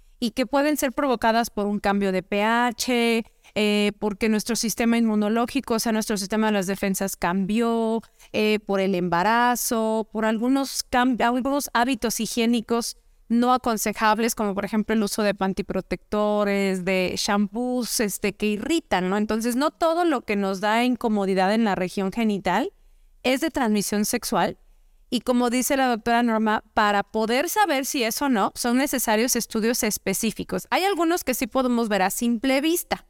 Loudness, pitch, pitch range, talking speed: -23 LUFS, 225 Hz, 205-245 Hz, 165 wpm